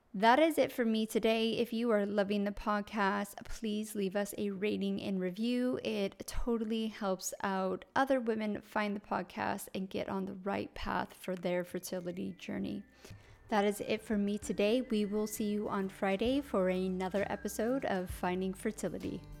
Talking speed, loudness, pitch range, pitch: 175 wpm, -35 LUFS, 195-225 Hz, 205 Hz